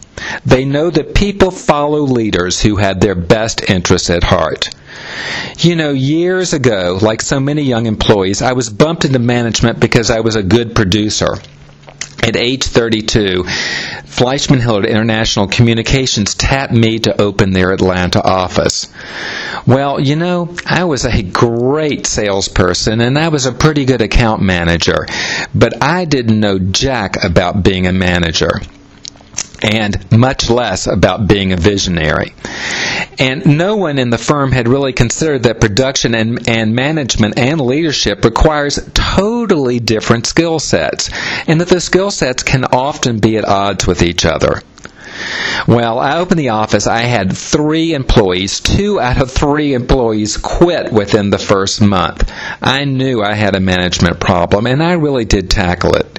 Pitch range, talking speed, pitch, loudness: 100-140 Hz, 155 wpm, 115 Hz, -12 LUFS